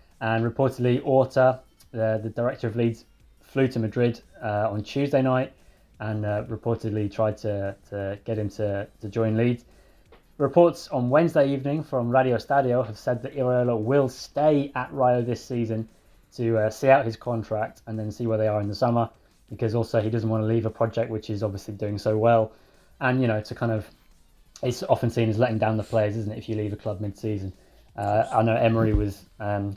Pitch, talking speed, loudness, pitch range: 115 Hz, 210 wpm, -25 LUFS, 110-125 Hz